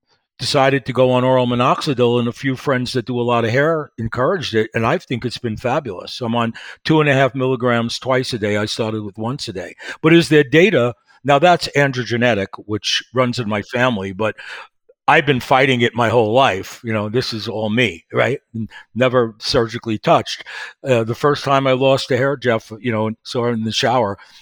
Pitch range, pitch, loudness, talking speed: 115-135 Hz, 125 Hz, -17 LUFS, 210 wpm